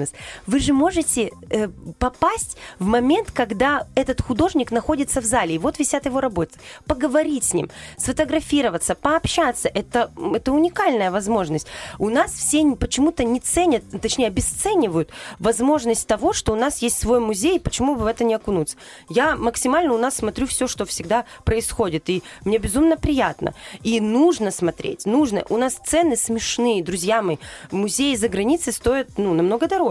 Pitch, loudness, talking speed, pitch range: 245 Hz, -20 LUFS, 160 wpm, 215-295 Hz